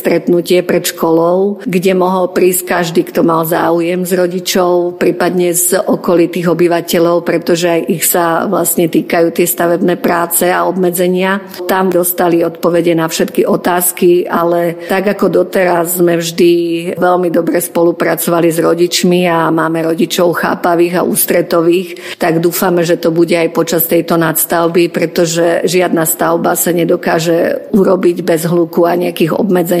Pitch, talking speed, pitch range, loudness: 175 Hz, 140 wpm, 170-180 Hz, -11 LUFS